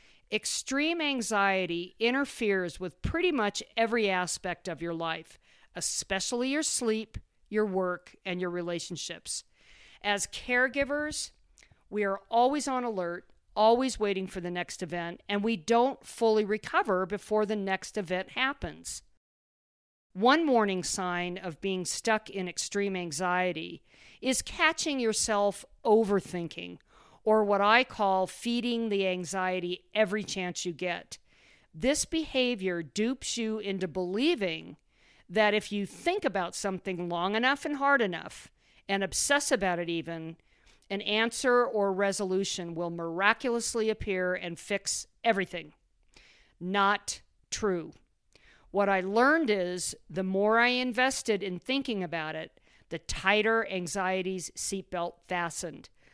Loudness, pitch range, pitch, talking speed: -29 LUFS, 180-230 Hz, 200 Hz, 125 wpm